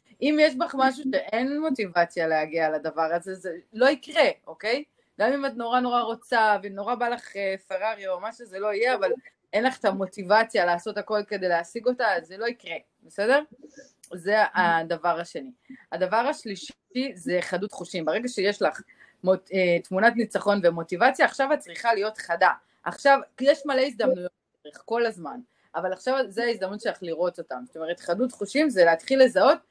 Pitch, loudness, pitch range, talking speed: 220 Hz, -25 LUFS, 180-260 Hz, 170 wpm